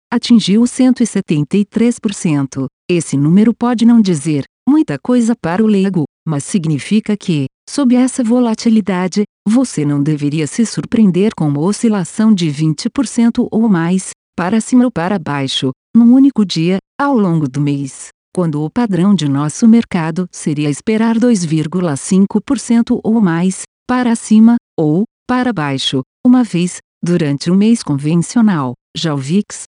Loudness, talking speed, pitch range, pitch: -14 LUFS, 135 wpm, 160-235 Hz, 200 Hz